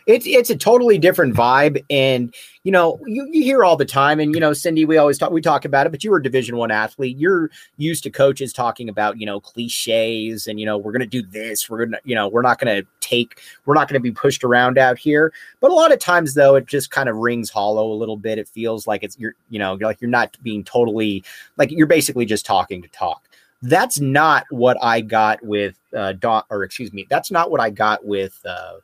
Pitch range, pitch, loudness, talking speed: 110-150 Hz, 120 Hz, -17 LUFS, 250 wpm